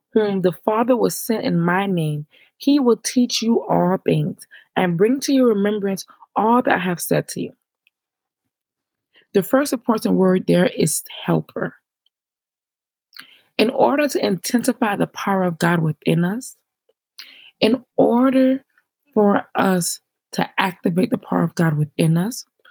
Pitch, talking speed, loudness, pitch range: 220 Hz, 145 wpm, -19 LUFS, 185-255 Hz